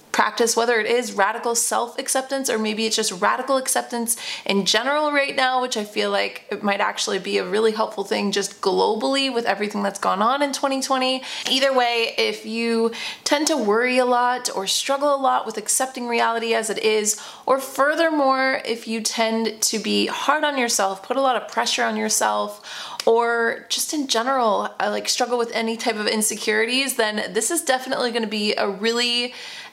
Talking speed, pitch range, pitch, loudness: 190 wpm, 215-265 Hz, 235 Hz, -21 LUFS